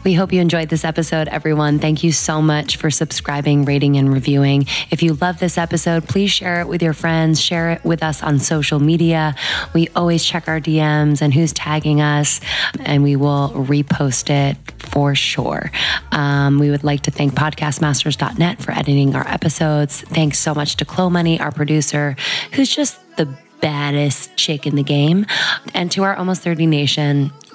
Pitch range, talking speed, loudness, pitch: 145-165 Hz, 180 wpm, -16 LUFS, 155 Hz